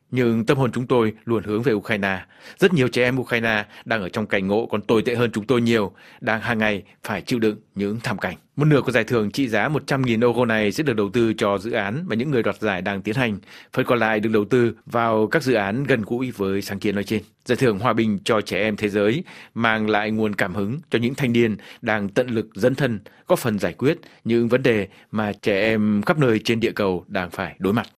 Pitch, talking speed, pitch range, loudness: 115 Hz, 255 wpm, 105-125 Hz, -22 LUFS